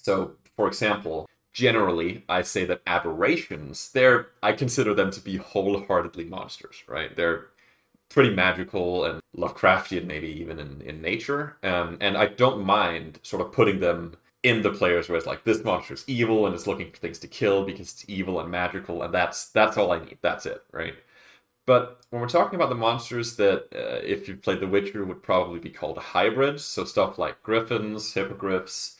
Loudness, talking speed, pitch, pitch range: -25 LUFS, 190 wpm, 100 Hz, 90-125 Hz